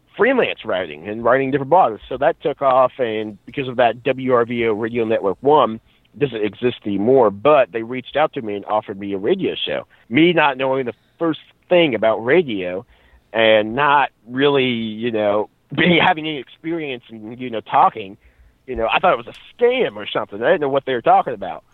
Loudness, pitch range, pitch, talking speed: -18 LUFS, 110-140 Hz, 120 Hz, 205 wpm